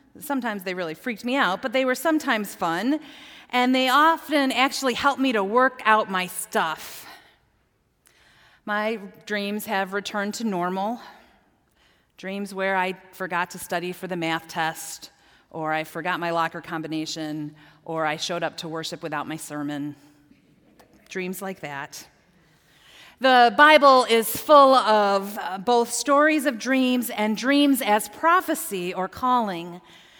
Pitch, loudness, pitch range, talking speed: 205 Hz, -22 LUFS, 170-255 Hz, 140 wpm